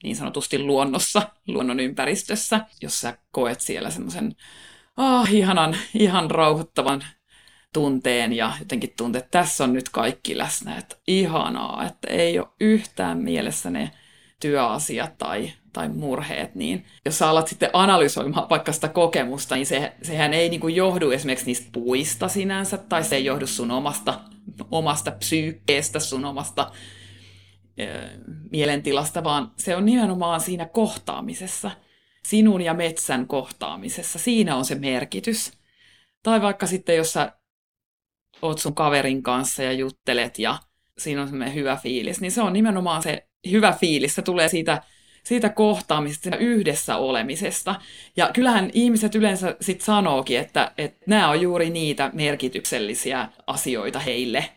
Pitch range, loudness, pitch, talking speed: 135-195 Hz, -23 LUFS, 160 Hz, 140 wpm